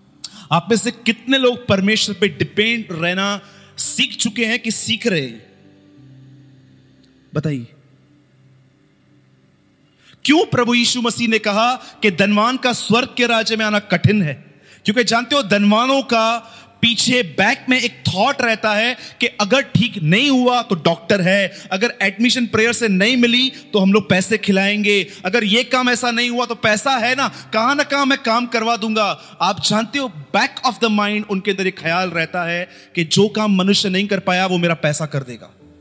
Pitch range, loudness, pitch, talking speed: 180-240 Hz, -16 LUFS, 210 Hz, 180 wpm